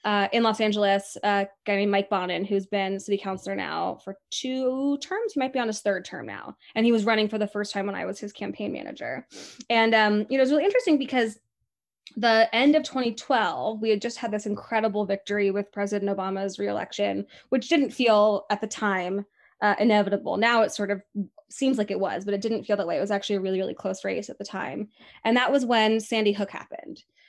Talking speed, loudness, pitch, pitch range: 230 wpm, -25 LUFS, 210 Hz, 200-235 Hz